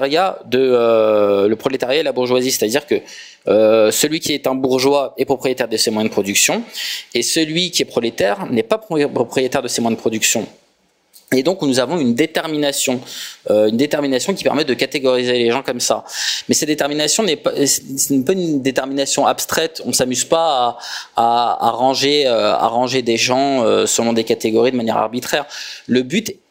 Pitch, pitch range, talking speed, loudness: 135 Hz, 120-150 Hz, 190 wpm, -16 LUFS